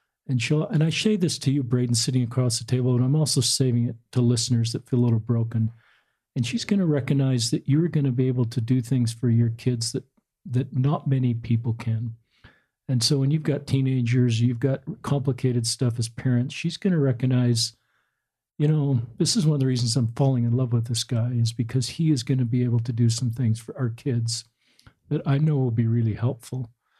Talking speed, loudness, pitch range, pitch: 225 wpm, -24 LUFS, 120-140 Hz, 125 Hz